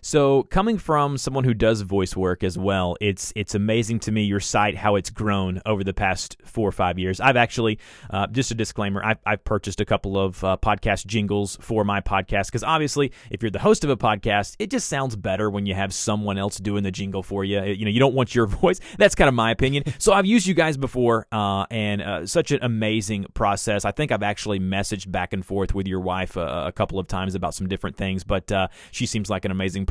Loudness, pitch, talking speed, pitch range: -23 LUFS, 105 Hz, 245 wpm, 95-115 Hz